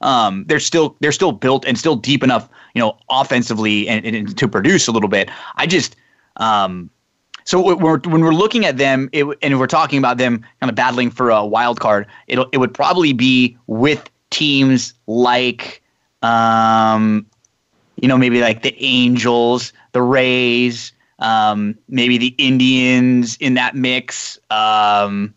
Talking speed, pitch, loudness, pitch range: 165 wpm, 125 Hz, -15 LUFS, 115-135 Hz